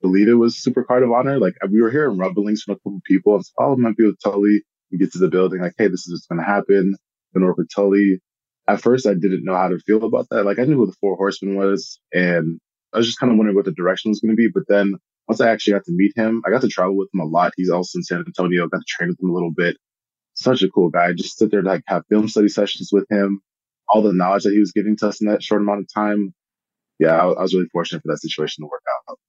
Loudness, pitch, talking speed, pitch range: -18 LUFS, 100 Hz, 295 wpm, 90-105 Hz